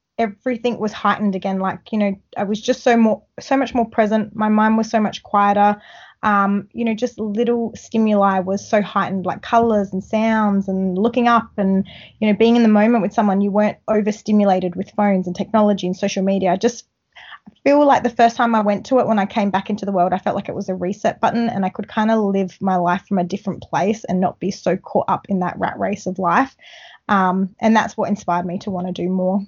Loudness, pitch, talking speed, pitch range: -18 LUFS, 205 Hz, 240 wpm, 190-225 Hz